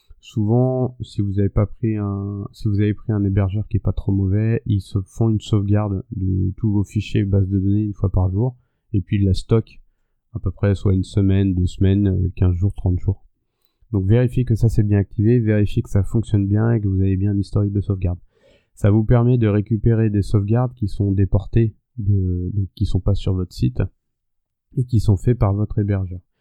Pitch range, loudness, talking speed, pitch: 95-110 Hz, -20 LUFS, 220 wpm, 100 Hz